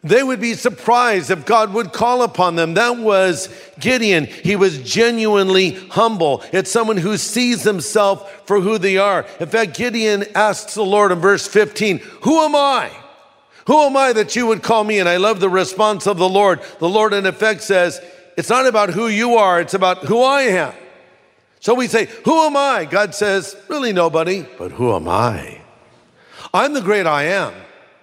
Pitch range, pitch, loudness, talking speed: 190-230 Hz, 205 Hz, -16 LUFS, 190 wpm